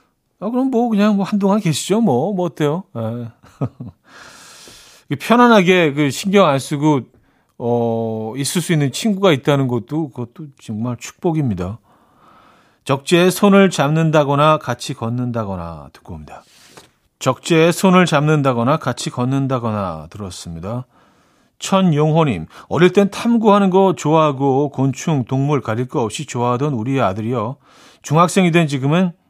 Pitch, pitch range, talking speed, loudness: 145 Hz, 120-180 Hz, 285 characters per minute, -16 LUFS